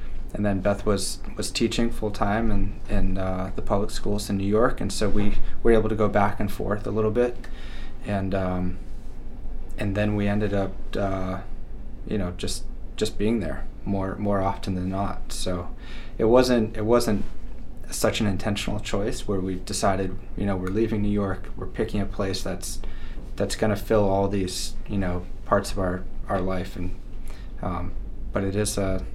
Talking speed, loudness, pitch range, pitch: 185 wpm, -26 LUFS, 95-110 Hz, 100 Hz